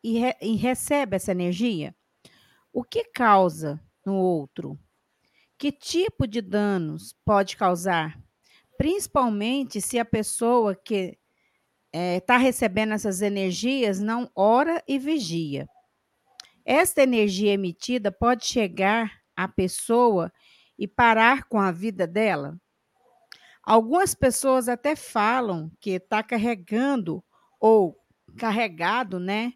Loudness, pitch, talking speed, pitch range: -24 LUFS, 220 Hz, 110 wpm, 190-250 Hz